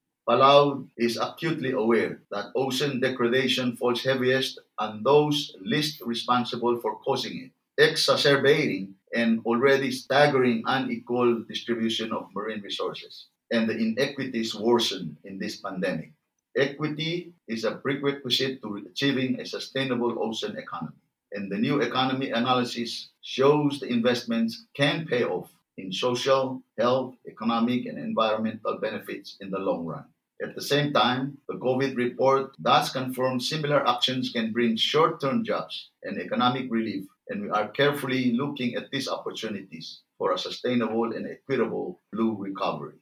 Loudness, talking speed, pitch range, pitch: -26 LUFS, 135 wpm, 115-135 Hz, 125 Hz